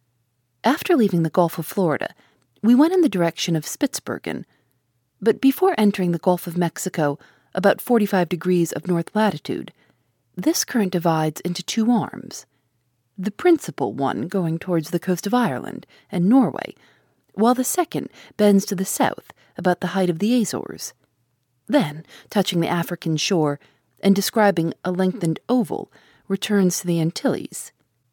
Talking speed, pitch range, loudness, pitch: 150 wpm, 160-210 Hz, -21 LUFS, 180 Hz